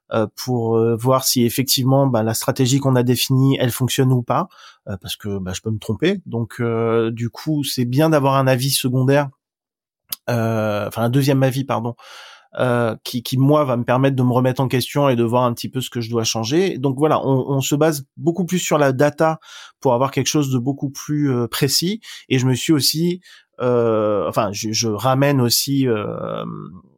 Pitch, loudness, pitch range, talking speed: 130 Hz, -19 LUFS, 115-140 Hz, 200 wpm